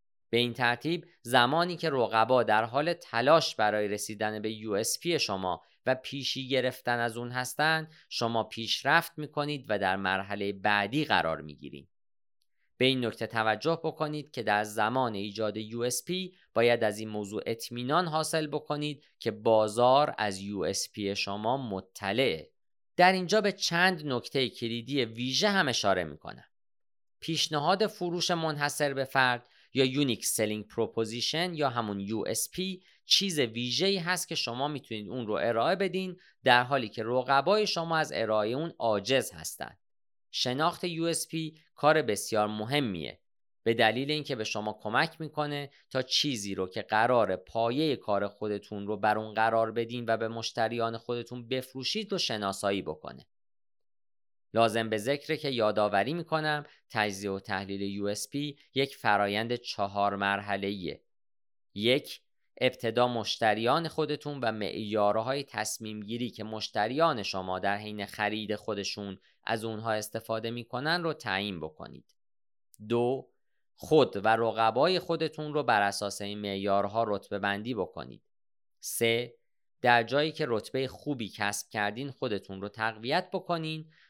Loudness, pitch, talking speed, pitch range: -30 LUFS, 120 Hz, 140 wpm, 105-150 Hz